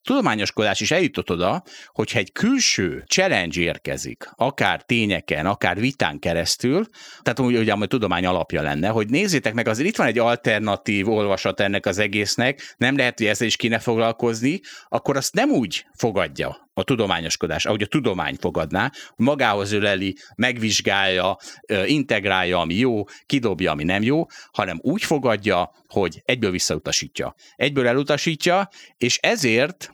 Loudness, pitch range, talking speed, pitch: -21 LUFS, 100-130 Hz, 140 wpm, 115 Hz